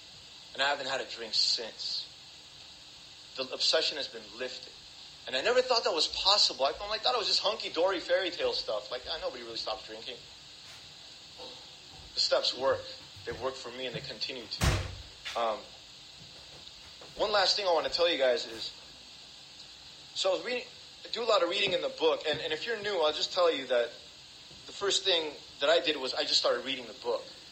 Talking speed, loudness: 200 wpm, -30 LUFS